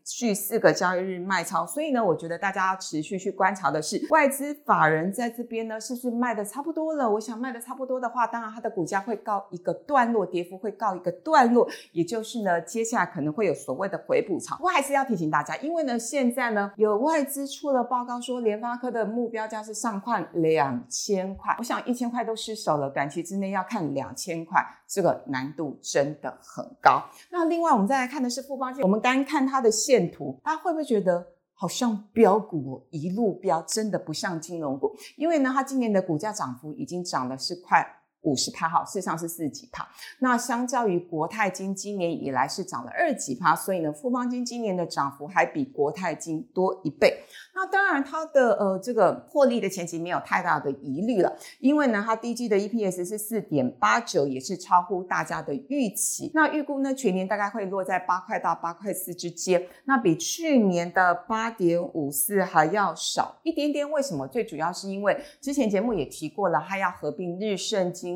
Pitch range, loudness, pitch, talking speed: 175-250 Hz, -26 LUFS, 205 Hz, 315 characters per minute